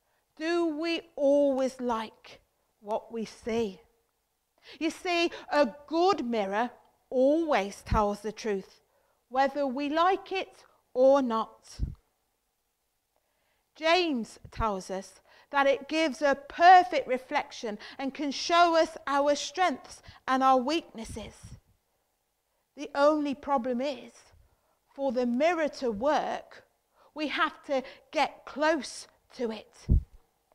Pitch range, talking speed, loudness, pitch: 245-320 Hz, 110 wpm, -28 LUFS, 280 Hz